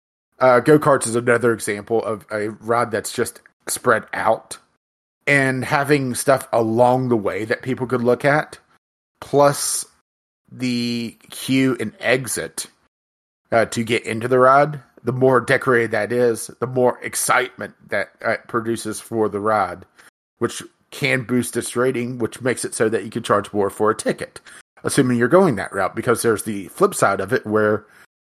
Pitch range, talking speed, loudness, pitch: 110-130 Hz, 170 wpm, -19 LUFS, 120 Hz